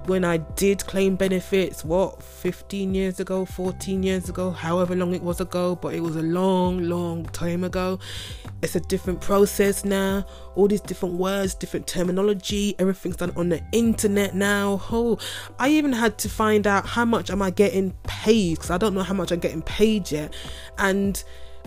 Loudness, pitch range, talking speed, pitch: -23 LUFS, 180-200 Hz, 185 wpm, 190 Hz